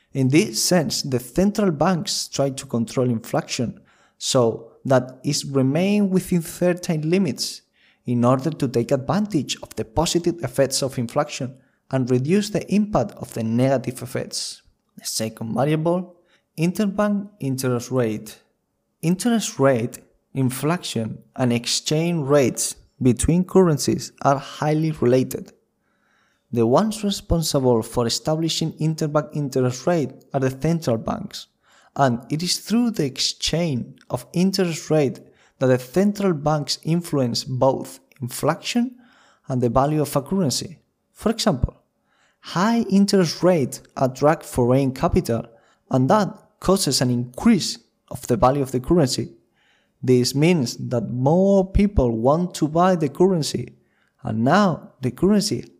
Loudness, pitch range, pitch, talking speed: -21 LUFS, 130-180 Hz, 150 Hz, 130 wpm